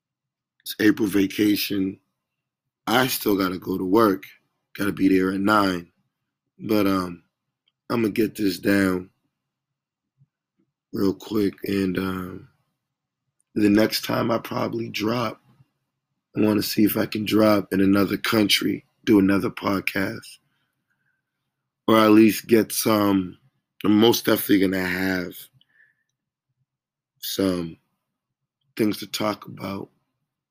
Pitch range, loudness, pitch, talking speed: 95-125 Hz, -22 LUFS, 105 Hz, 115 wpm